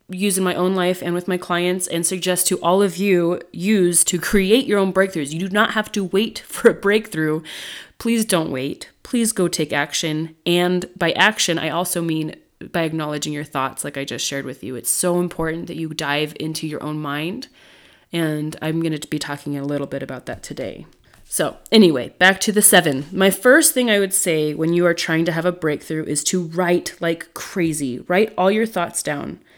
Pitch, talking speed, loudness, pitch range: 175 Hz, 215 wpm, -19 LUFS, 155-190 Hz